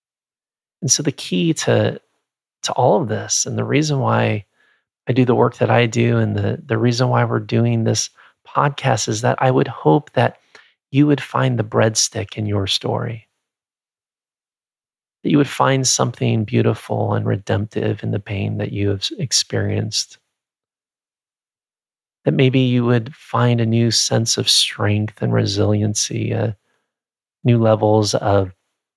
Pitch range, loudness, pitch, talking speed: 105-125 Hz, -18 LUFS, 115 Hz, 155 wpm